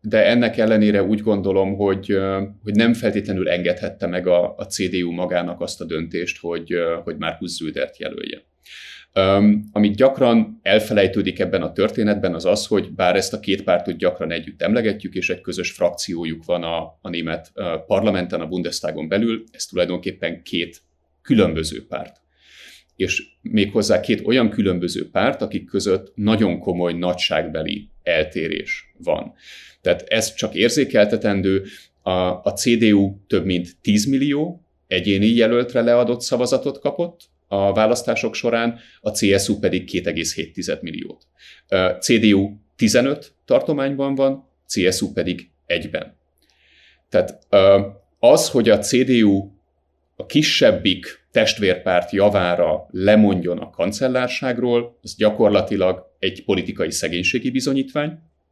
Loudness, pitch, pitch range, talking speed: -19 LUFS, 100 Hz, 90-120 Hz, 125 wpm